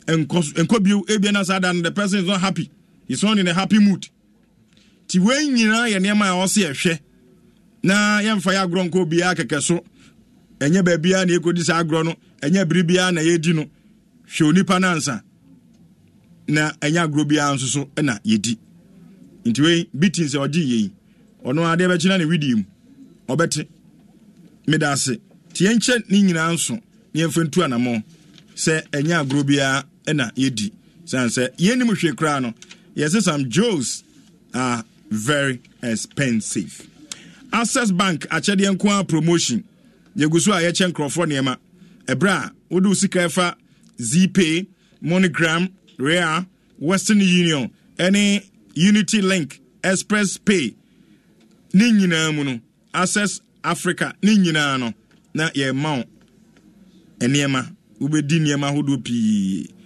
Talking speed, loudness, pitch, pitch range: 145 wpm, -19 LUFS, 175 Hz, 150-195 Hz